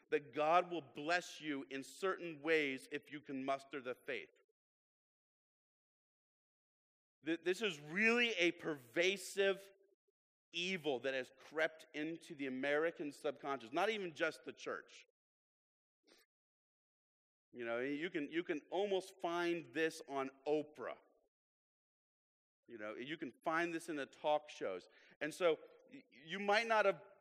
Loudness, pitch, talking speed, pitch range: -40 LUFS, 170 Hz, 130 wpm, 150-205 Hz